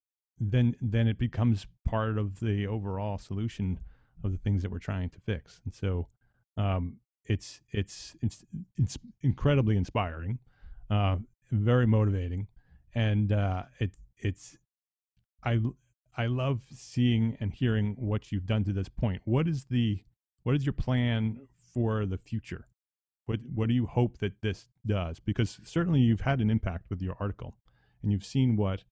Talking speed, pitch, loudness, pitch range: 160 wpm, 110 Hz, -31 LUFS, 100-120 Hz